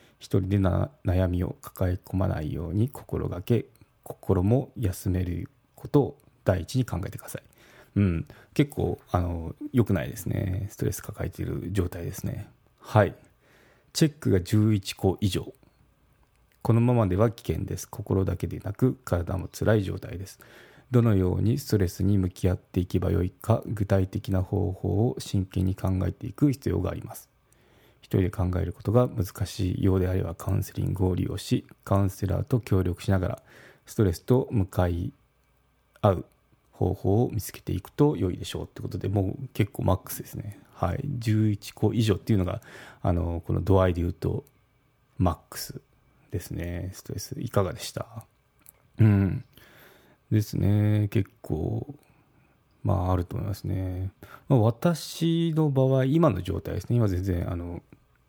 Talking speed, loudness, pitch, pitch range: 300 characters per minute, -27 LUFS, 105 Hz, 95-120 Hz